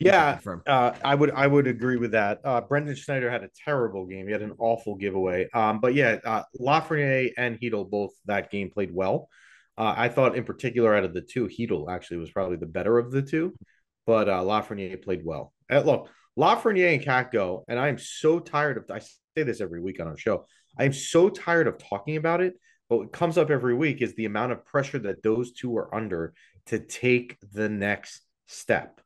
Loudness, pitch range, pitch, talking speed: -26 LUFS, 100-140 Hz, 120 Hz, 215 wpm